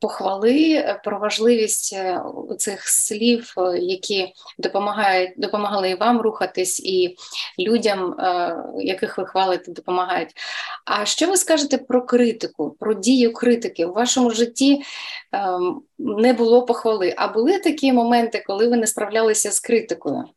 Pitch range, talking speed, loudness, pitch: 195-250 Hz, 125 wpm, -20 LUFS, 220 Hz